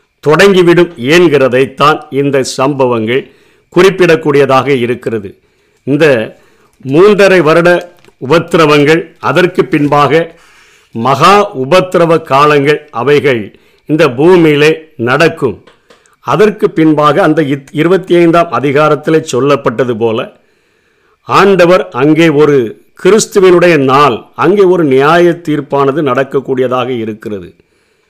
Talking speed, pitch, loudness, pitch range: 80 wpm, 155 Hz, -8 LUFS, 135-175 Hz